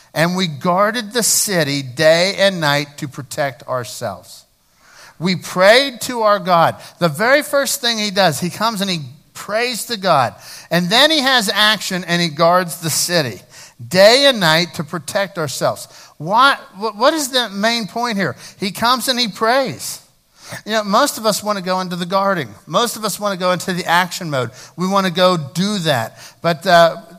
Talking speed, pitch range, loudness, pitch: 190 wpm, 165-220 Hz, -16 LUFS, 185 Hz